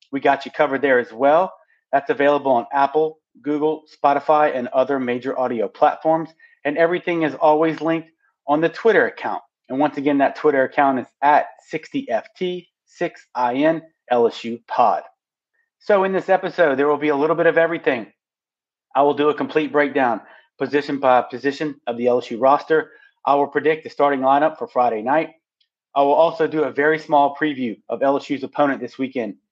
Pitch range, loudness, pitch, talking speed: 140-160 Hz, -19 LUFS, 150 Hz, 170 wpm